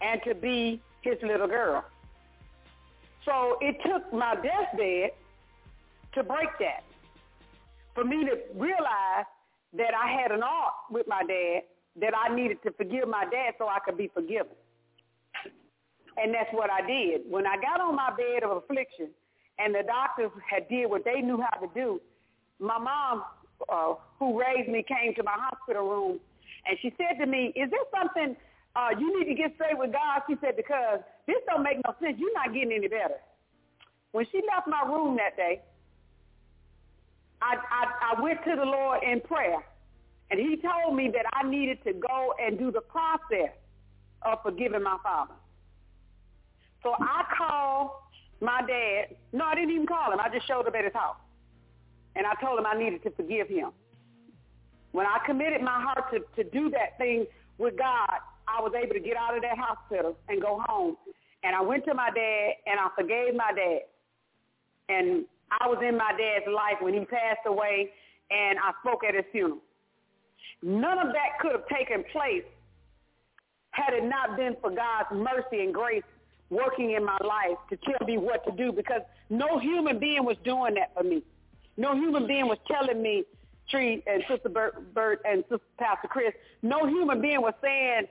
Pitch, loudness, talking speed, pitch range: 245 Hz, -29 LUFS, 185 wpm, 205-290 Hz